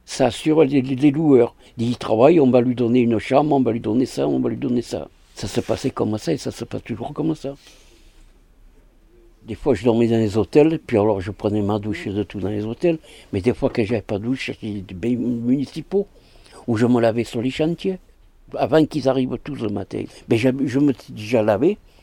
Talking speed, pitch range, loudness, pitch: 230 wpm, 105-135 Hz, -20 LUFS, 120 Hz